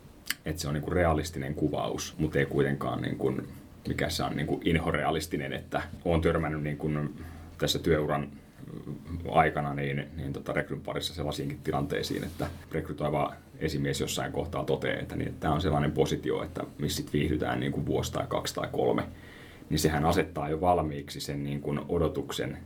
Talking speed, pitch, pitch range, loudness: 160 wpm, 75 Hz, 70-80 Hz, -30 LUFS